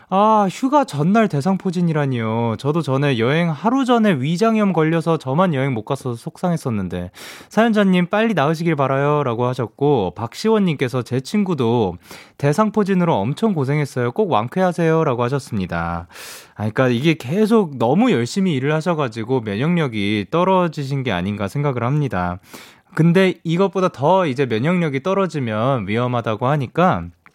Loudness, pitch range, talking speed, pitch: -19 LUFS, 125-185 Hz, 355 characters per minute, 150 Hz